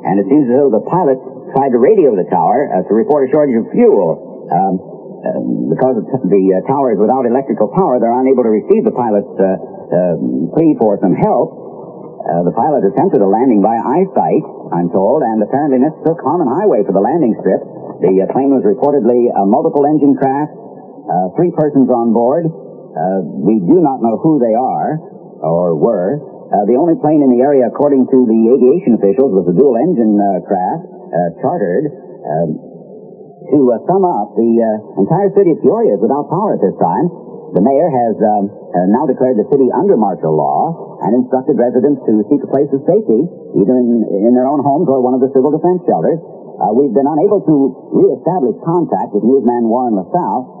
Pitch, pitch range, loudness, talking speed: 125 Hz, 110-140 Hz, -13 LUFS, 195 wpm